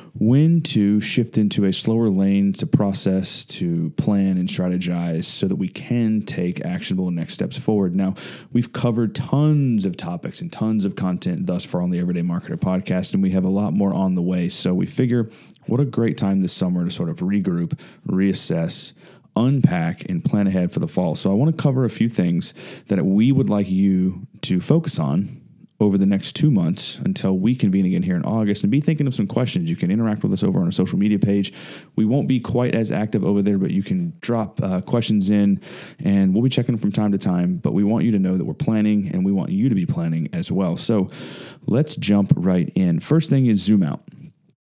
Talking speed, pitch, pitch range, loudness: 225 wpm, 110 Hz, 95-160 Hz, -20 LUFS